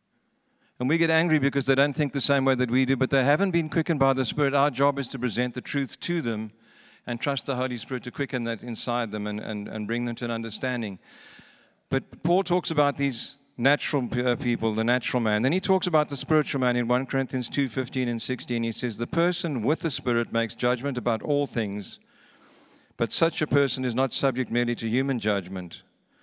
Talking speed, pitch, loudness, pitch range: 215 wpm, 130 Hz, -26 LUFS, 120-145 Hz